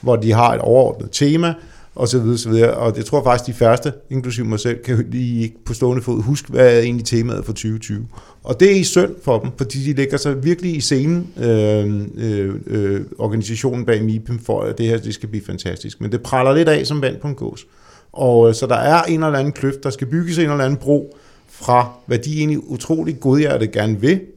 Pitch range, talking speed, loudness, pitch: 115-145 Hz, 230 wpm, -17 LUFS, 125 Hz